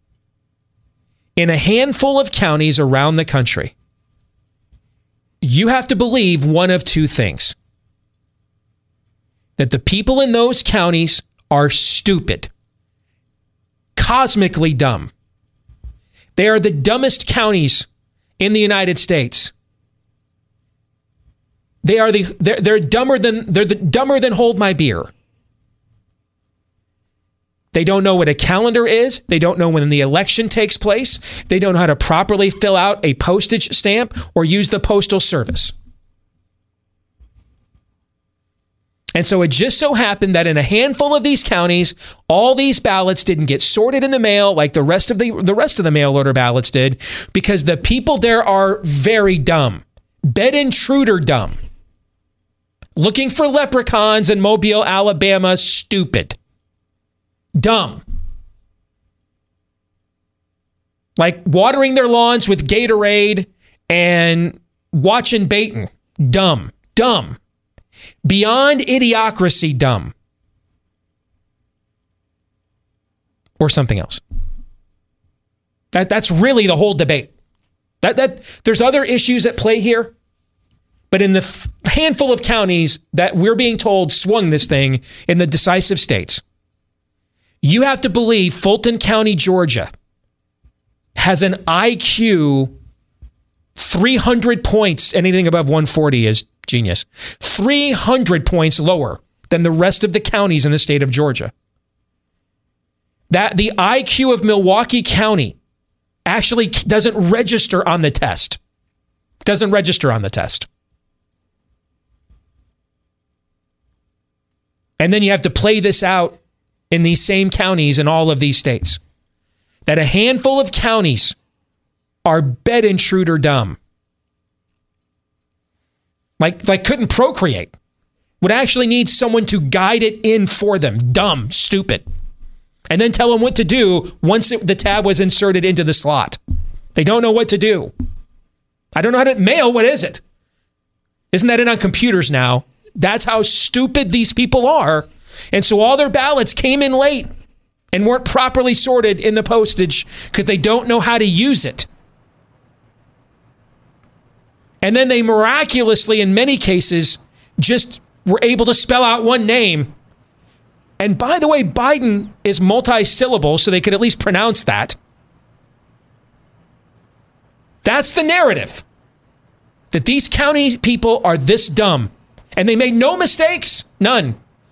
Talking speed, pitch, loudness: 130 wpm, 175 Hz, -13 LUFS